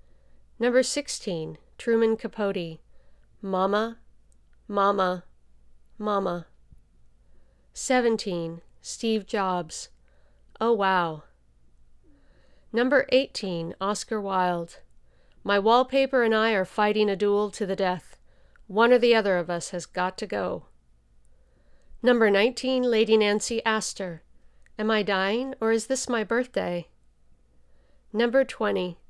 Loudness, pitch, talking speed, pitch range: -25 LUFS, 200 Hz, 105 wpm, 170-225 Hz